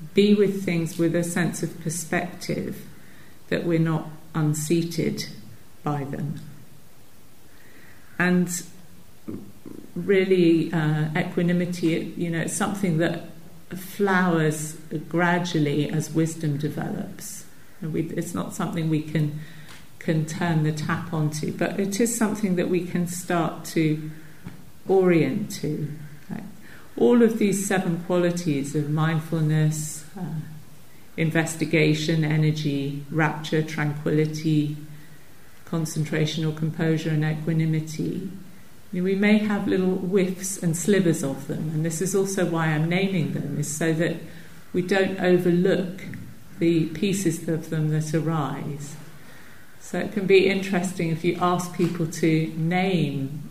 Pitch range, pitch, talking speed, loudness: 155-180 Hz, 165 Hz, 120 wpm, -24 LUFS